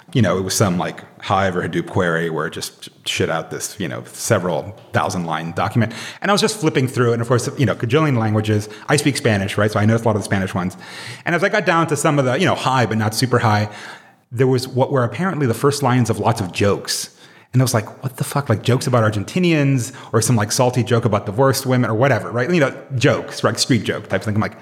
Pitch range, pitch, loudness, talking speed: 105-135 Hz, 120 Hz, -18 LUFS, 270 wpm